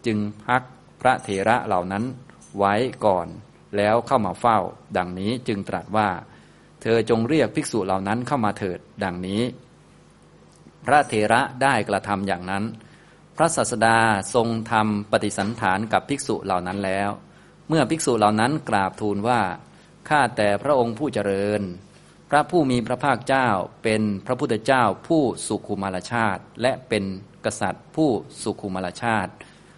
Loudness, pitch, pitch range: -23 LUFS, 110 Hz, 100-125 Hz